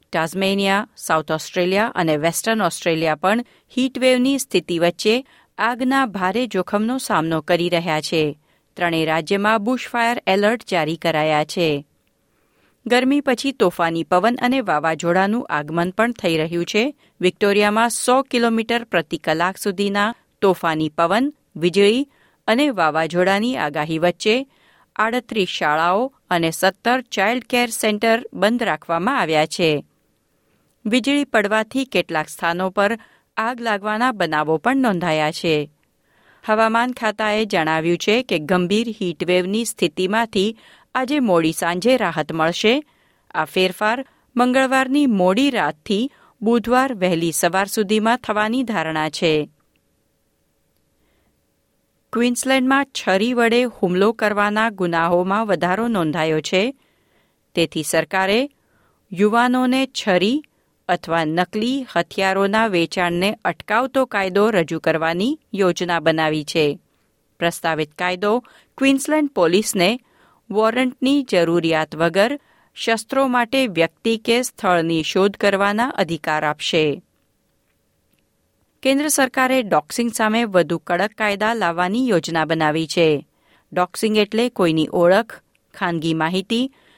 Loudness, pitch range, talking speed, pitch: -19 LUFS, 170-235 Hz, 105 wpm, 200 Hz